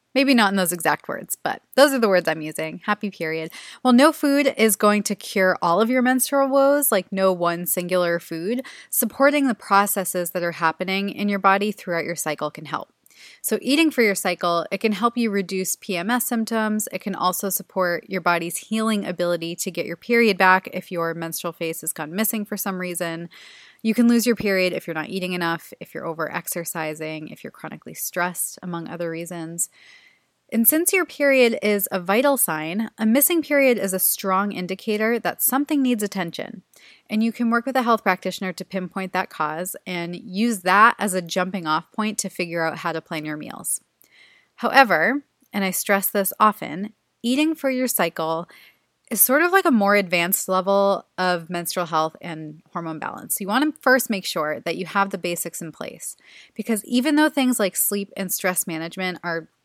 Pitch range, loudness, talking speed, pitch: 175-230 Hz, -21 LUFS, 195 wpm, 195 Hz